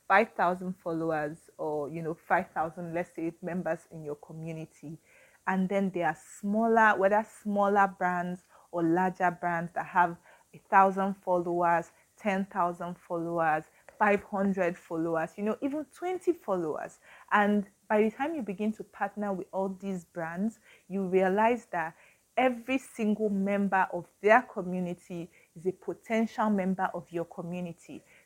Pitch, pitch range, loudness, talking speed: 185 Hz, 170-205 Hz, -30 LUFS, 145 wpm